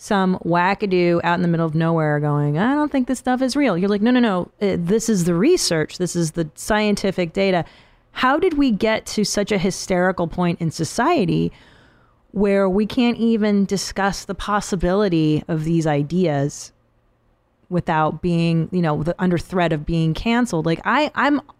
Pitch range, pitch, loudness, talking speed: 165-210 Hz, 180 Hz, -19 LUFS, 180 wpm